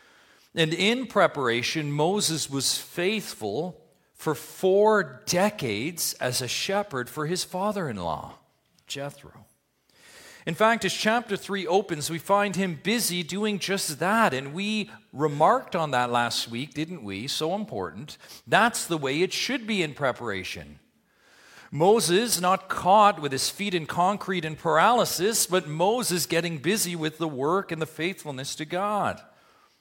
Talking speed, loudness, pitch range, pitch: 145 wpm, -25 LUFS, 150-200 Hz, 175 Hz